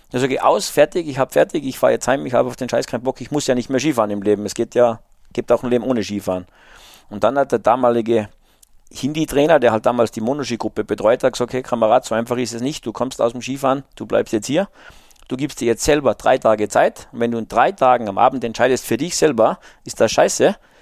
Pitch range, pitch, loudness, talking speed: 110-130 Hz, 120 Hz, -18 LUFS, 255 wpm